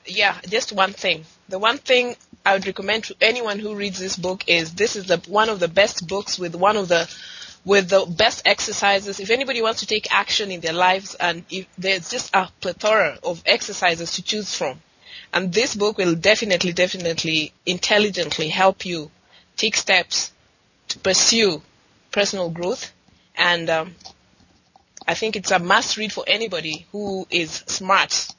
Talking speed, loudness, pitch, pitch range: 170 wpm, -20 LUFS, 195 Hz, 175-210 Hz